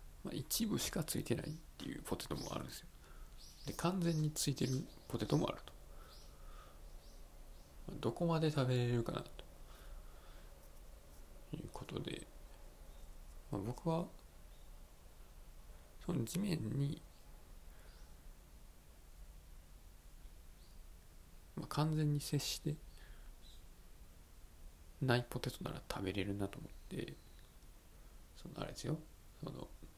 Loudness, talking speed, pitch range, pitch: -41 LUFS, 180 characters per minute, 75-100 Hz, 80 Hz